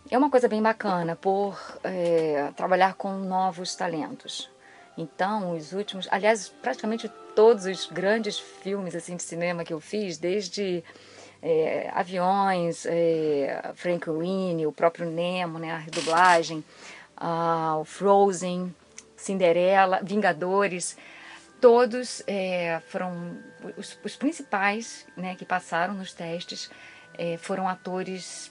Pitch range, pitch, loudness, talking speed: 170-200 Hz, 185 Hz, -26 LUFS, 120 wpm